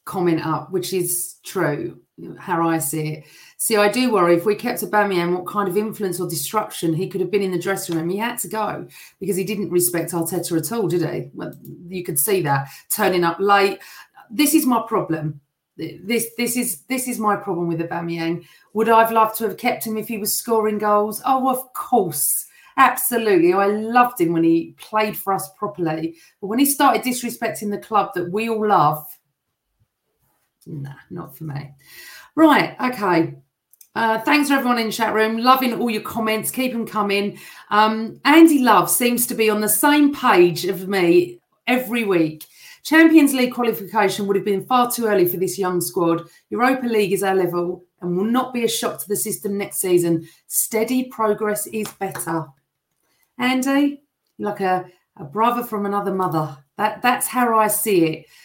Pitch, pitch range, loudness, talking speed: 205 Hz, 175-230 Hz, -19 LUFS, 190 wpm